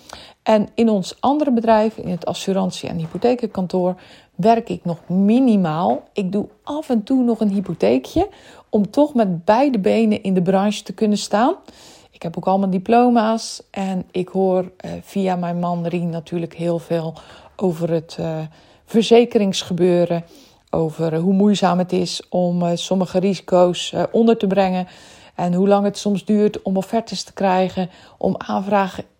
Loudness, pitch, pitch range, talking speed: -19 LUFS, 190 Hz, 175-215 Hz, 150 wpm